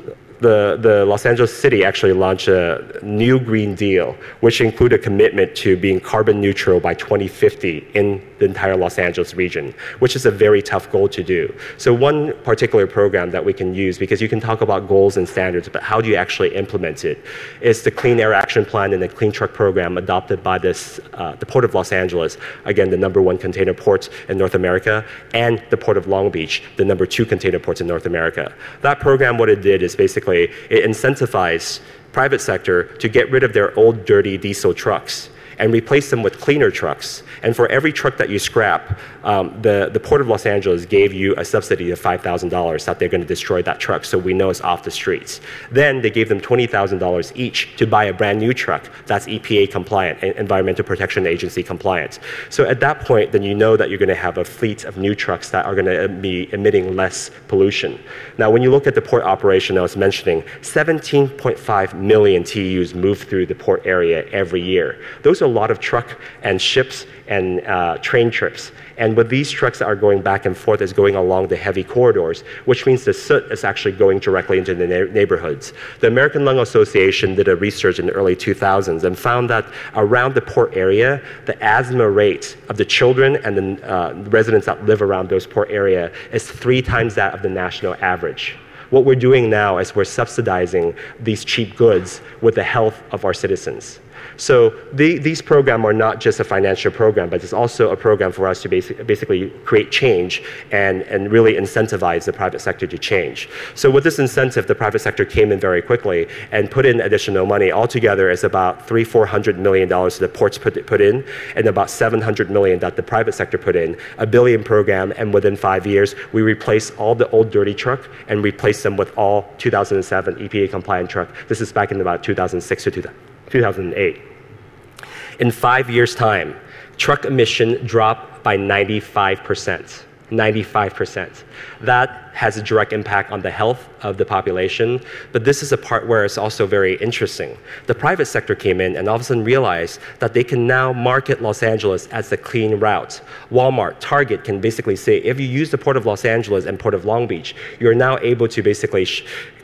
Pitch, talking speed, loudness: 140 Hz, 200 wpm, -17 LUFS